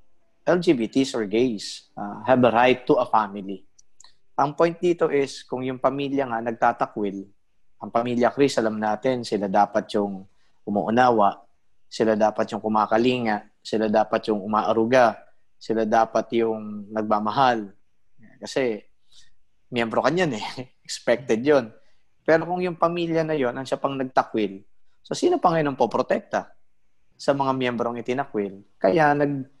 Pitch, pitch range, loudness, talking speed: 115 Hz, 105-135 Hz, -23 LUFS, 140 wpm